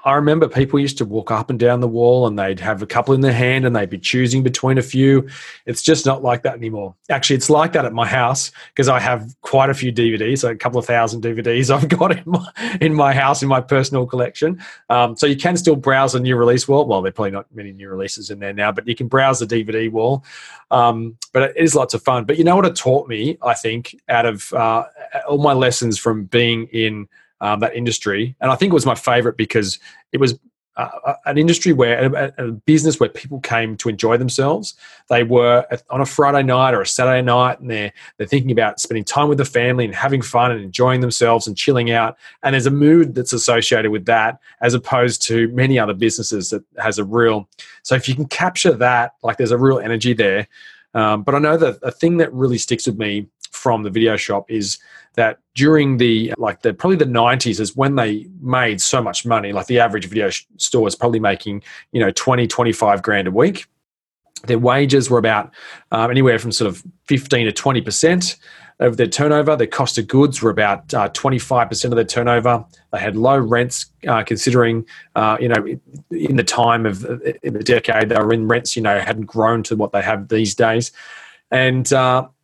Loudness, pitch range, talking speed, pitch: -17 LUFS, 115-135 Hz, 225 wpm, 120 Hz